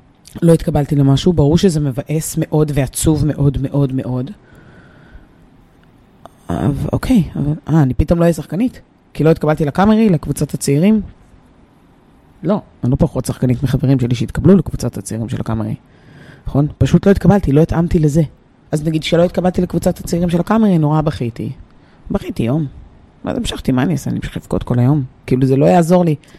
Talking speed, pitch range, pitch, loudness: 160 wpm, 130-170 Hz, 150 Hz, -15 LUFS